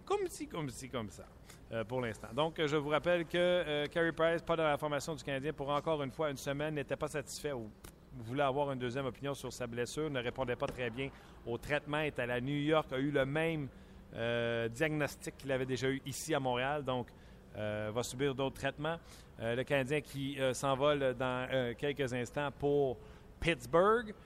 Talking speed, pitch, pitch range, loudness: 210 wpm, 140 Hz, 125-150 Hz, -36 LUFS